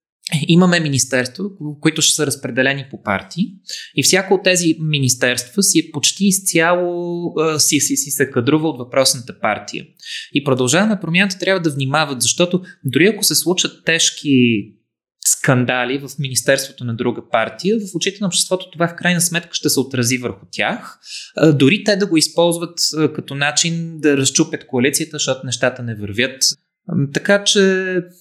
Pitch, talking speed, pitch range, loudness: 155 Hz, 160 wpm, 135-175 Hz, -16 LUFS